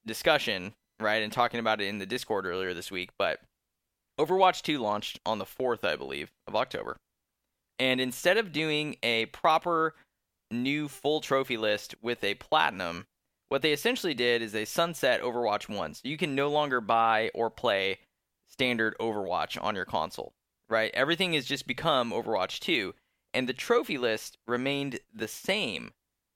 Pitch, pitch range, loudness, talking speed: 125 Hz, 110-150 Hz, -29 LUFS, 165 wpm